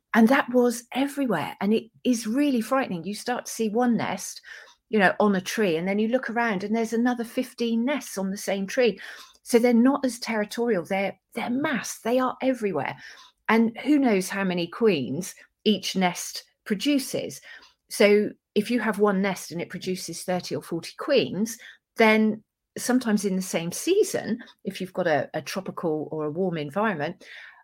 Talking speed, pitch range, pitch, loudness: 180 wpm, 190-245 Hz, 220 Hz, -25 LUFS